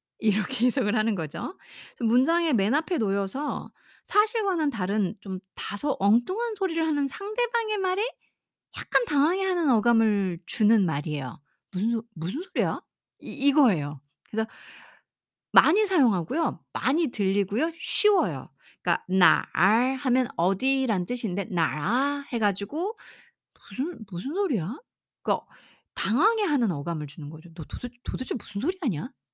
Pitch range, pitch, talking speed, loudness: 195-315 Hz, 235 Hz, 290 characters per minute, -26 LUFS